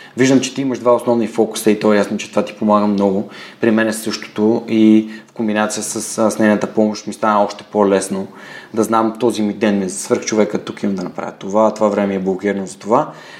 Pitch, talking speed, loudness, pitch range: 105 Hz, 225 wpm, -16 LUFS, 105-110 Hz